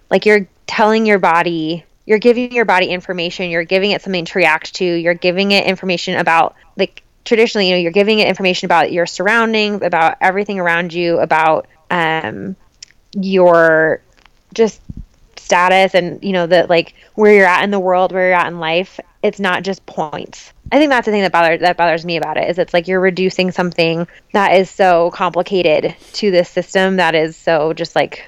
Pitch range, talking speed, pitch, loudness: 170-195 Hz, 195 wpm, 180 Hz, -14 LUFS